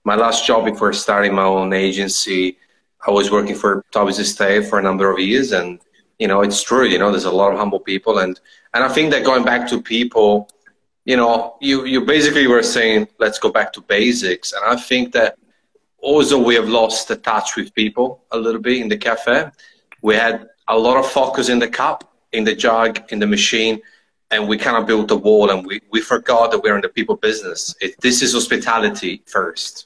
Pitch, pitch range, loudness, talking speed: 115 Hz, 105-125 Hz, -16 LUFS, 215 wpm